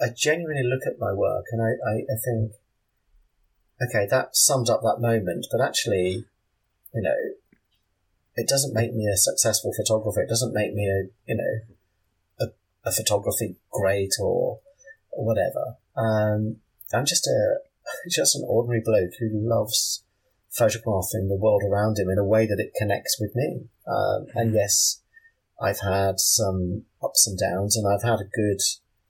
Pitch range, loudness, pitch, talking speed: 100-115 Hz, -24 LUFS, 105 Hz, 165 wpm